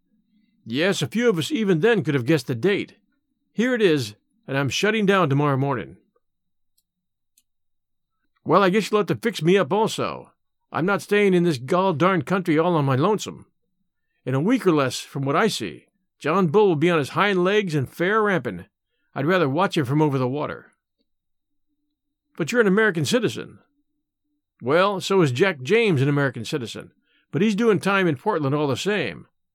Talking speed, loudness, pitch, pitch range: 190 wpm, -21 LUFS, 185 Hz, 150-215 Hz